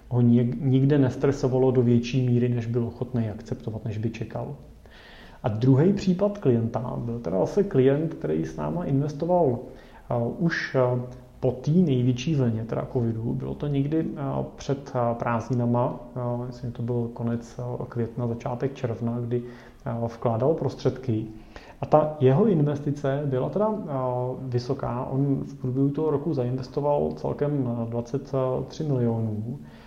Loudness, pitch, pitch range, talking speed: -26 LUFS, 125 Hz, 120-140 Hz, 125 wpm